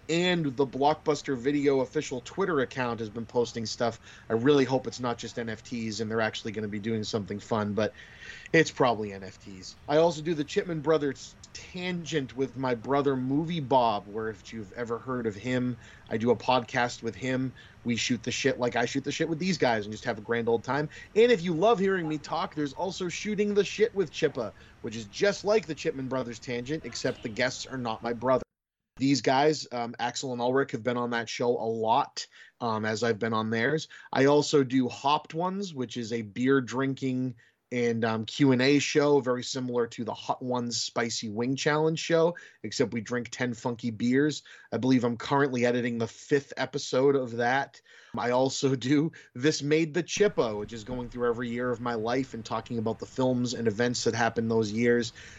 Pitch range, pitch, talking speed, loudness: 115-145 Hz, 125 Hz, 205 wpm, -28 LUFS